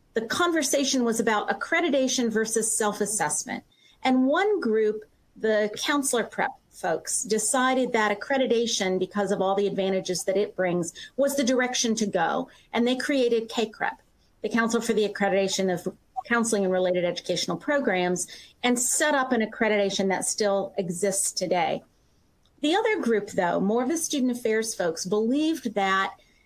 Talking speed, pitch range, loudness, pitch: 150 wpm, 195-255 Hz, -25 LUFS, 220 Hz